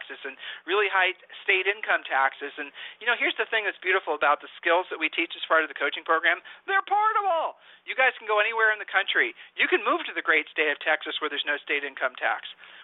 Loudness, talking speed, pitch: -25 LUFS, 235 wpm, 210 Hz